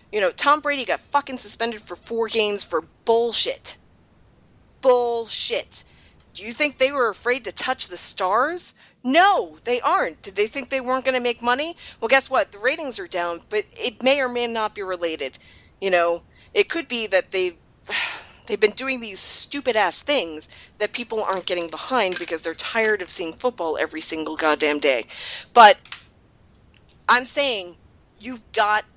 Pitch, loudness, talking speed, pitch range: 230 Hz, -22 LUFS, 175 wpm, 175-270 Hz